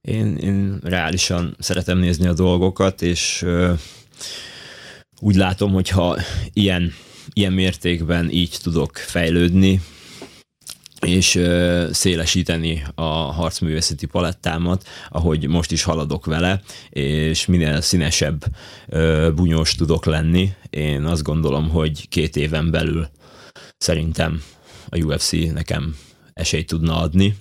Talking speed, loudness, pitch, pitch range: 110 wpm, -19 LUFS, 85 Hz, 80-90 Hz